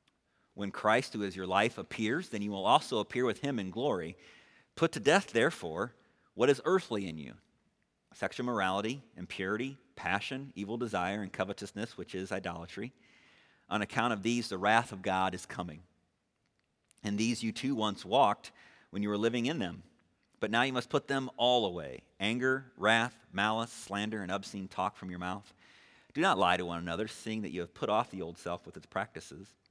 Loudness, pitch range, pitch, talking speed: -33 LUFS, 95-120 Hz, 105 Hz, 190 wpm